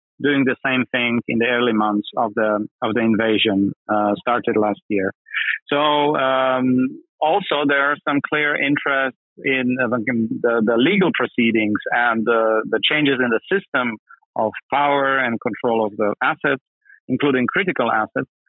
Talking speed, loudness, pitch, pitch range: 160 wpm, -19 LUFS, 125 Hz, 115-140 Hz